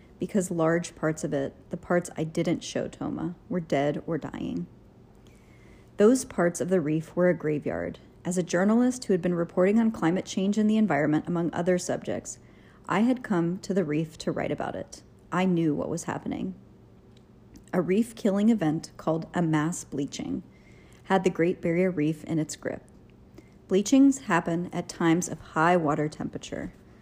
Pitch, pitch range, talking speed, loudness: 175 Hz, 155-190 Hz, 175 wpm, -27 LUFS